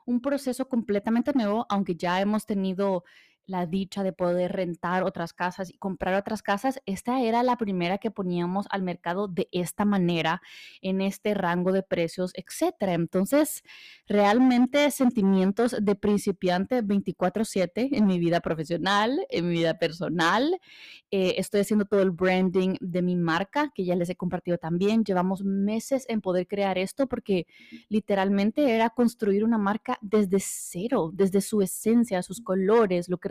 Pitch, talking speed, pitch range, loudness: 195 Hz, 155 wpm, 180-225 Hz, -26 LUFS